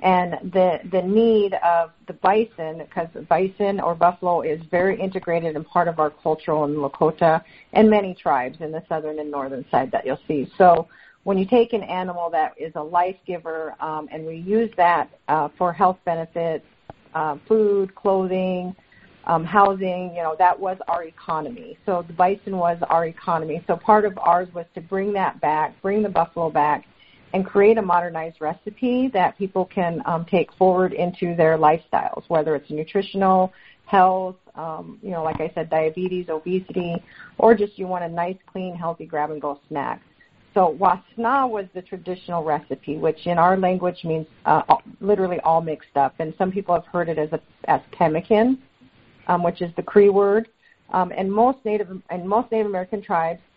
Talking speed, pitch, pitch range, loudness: 180 wpm, 175 Hz, 160-195 Hz, -21 LUFS